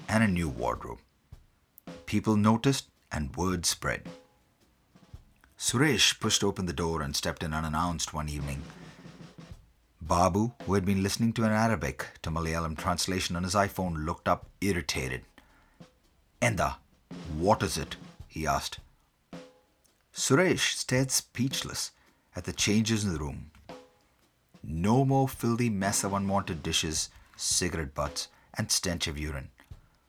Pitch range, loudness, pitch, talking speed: 80-100 Hz, -29 LUFS, 90 Hz, 130 wpm